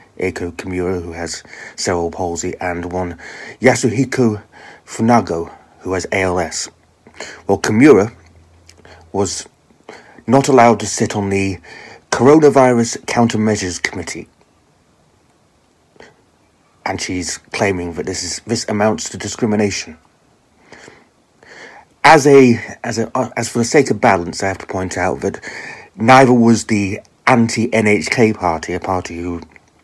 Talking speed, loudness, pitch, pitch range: 120 wpm, -15 LUFS, 100 Hz, 90-115 Hz